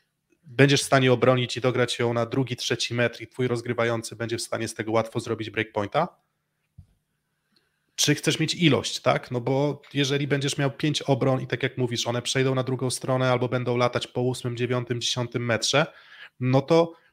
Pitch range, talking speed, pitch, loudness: 120-140 Hz, 185 wpm, 125 Hz, -25 LUFS